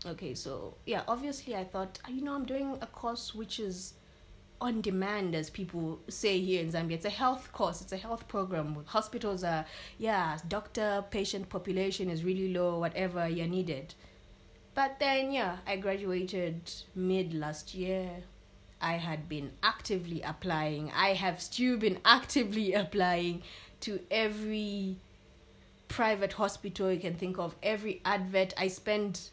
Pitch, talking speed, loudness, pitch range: 190 Hz, 150 wpm, -33 LUFS, 170-210 Hz